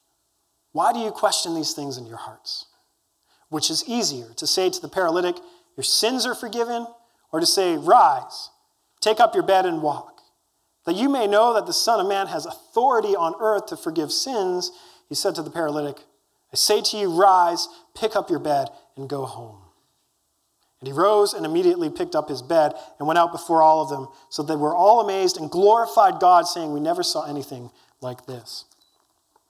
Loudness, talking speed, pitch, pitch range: -21 LUFS, 195 wpm, 180 Hz, 155-235 Hz